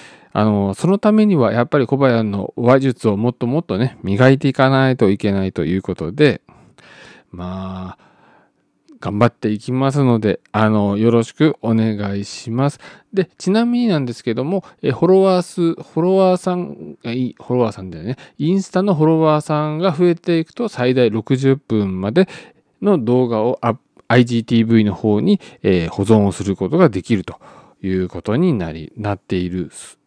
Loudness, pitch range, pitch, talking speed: -17 LUFS, 105-160 Hz, 125 Hz, 325 characters per minute